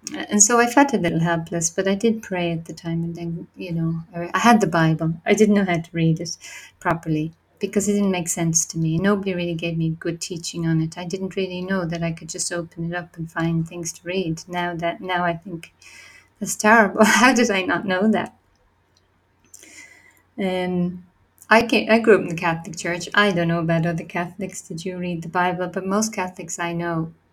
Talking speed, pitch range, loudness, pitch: 220 wpm, 165-195 Hz, -21 LUFS, 175 Hz